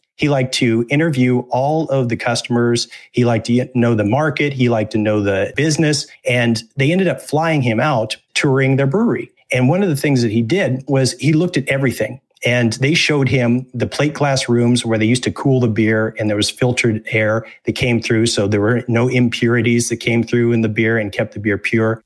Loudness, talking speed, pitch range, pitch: -16 LUFS, 225 wpm, 115-135 Hz, 120 Hz